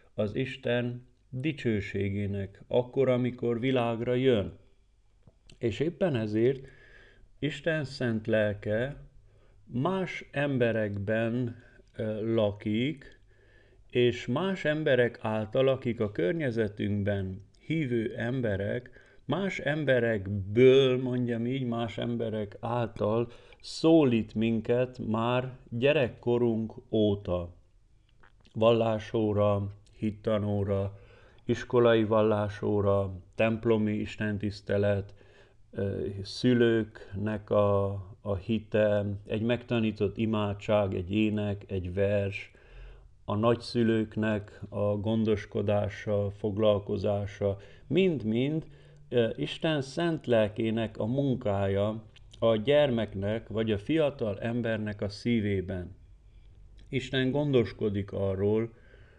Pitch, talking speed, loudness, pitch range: 110 Hz, 75 wpm, -29 LUFS, 100-120 Hz